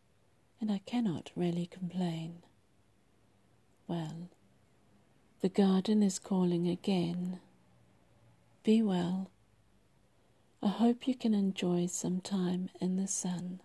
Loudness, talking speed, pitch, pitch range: -33 LUFS, 100 wpm, 180 Hz, 170-195 Hz